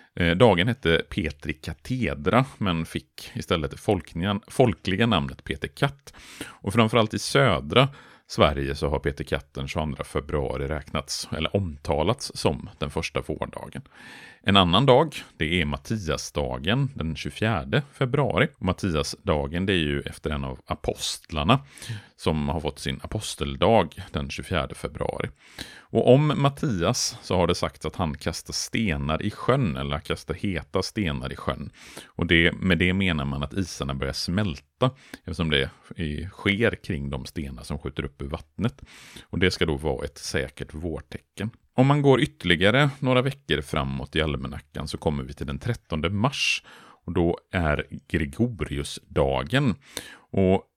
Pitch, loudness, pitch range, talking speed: 85 Hz, -25 LUFS, 75-105 Hz, 145 wpm